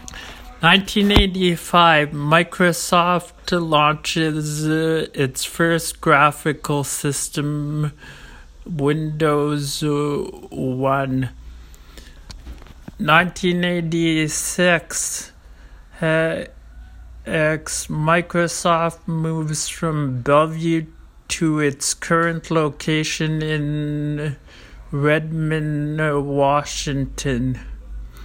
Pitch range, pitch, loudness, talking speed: 135-165 Hz, 150 Hz, -19 LUFS, 45 wpm